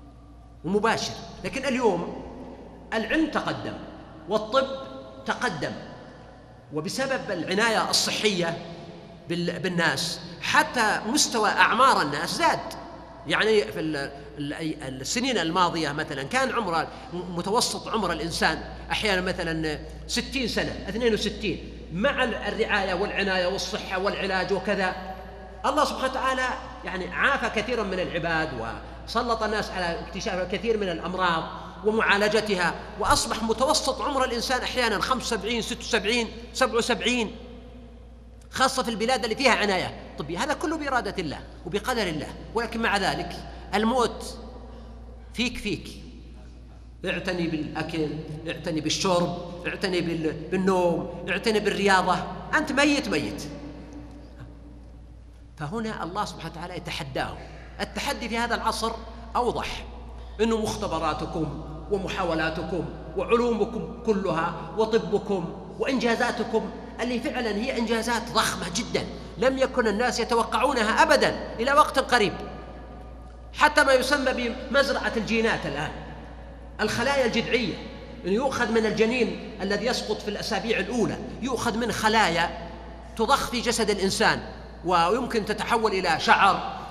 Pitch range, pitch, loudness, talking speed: 170-235 Hz, 210 Hz, -25 LUFS, 105 wpm